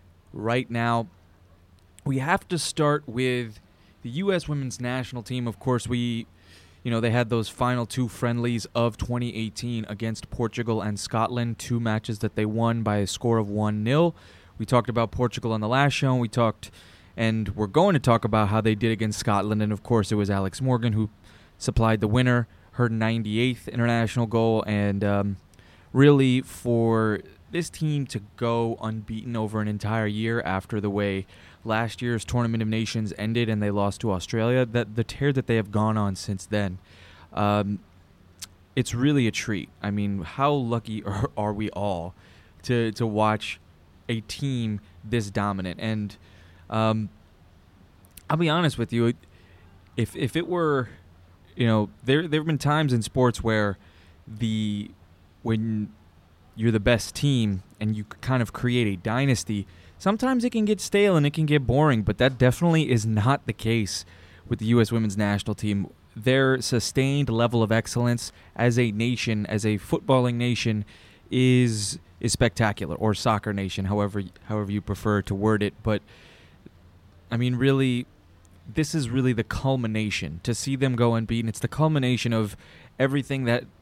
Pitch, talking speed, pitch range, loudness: 110 Hz, 170 wpm, 100-120 Hz, -25 LUFS